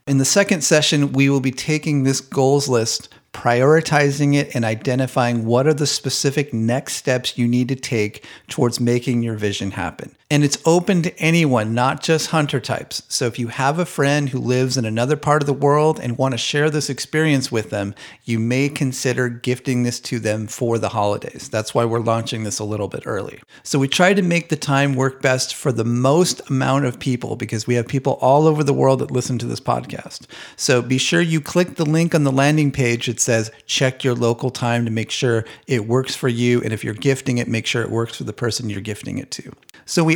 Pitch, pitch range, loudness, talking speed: 130 Hz, 120-145 Hz, -19 LUFS, 225 wpm